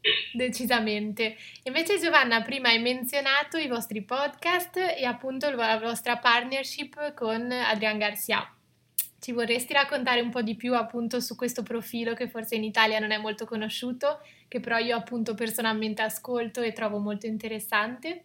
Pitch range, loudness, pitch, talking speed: 225-265 Hz, -27 LUFS, 235 Hz, 150 wpm